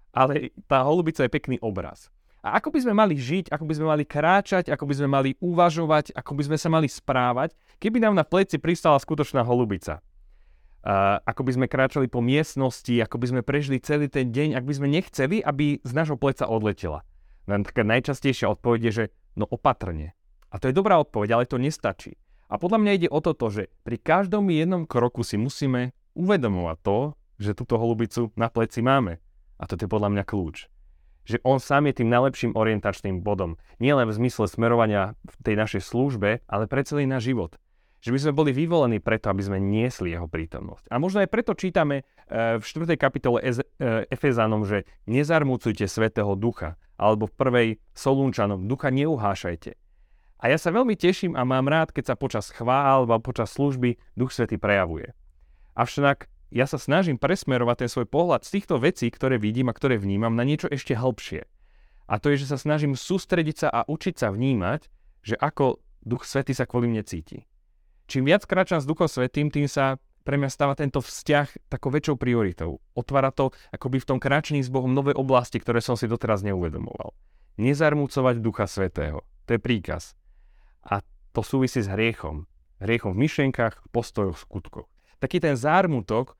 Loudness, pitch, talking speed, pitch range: -24 LUFS, 125 Hz, 180 wpm, 105-145 Hz